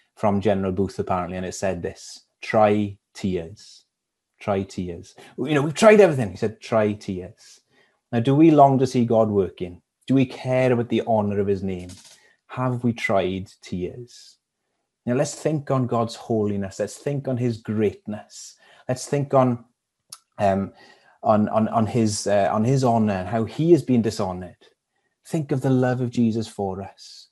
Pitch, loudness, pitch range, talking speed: 110 Hz, -22 LUFS, 100-130 Hz, 175 wpm